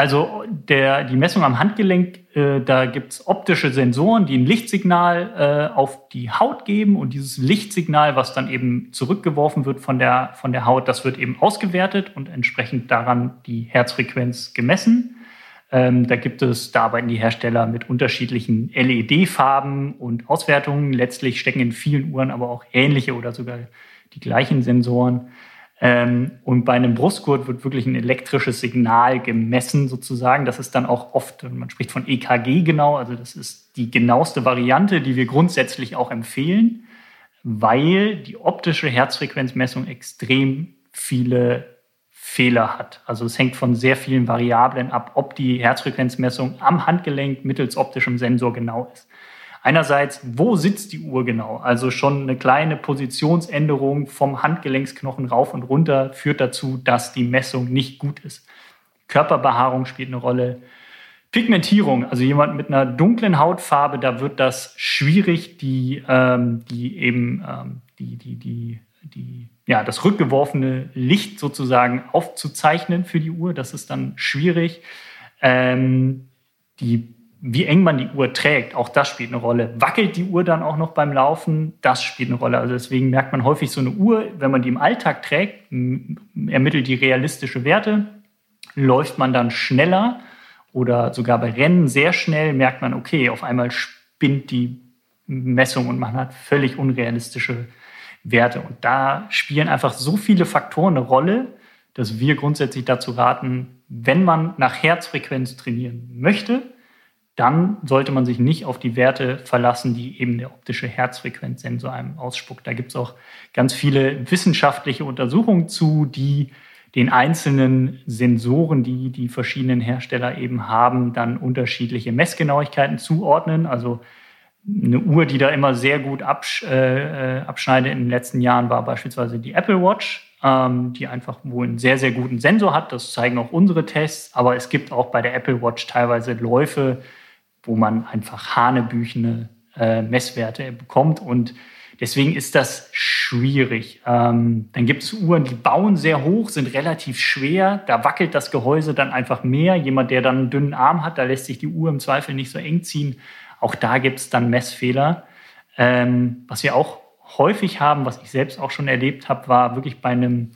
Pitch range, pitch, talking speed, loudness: 125-150 Hz, 130 Hz, 160 wpm, -19 LUFS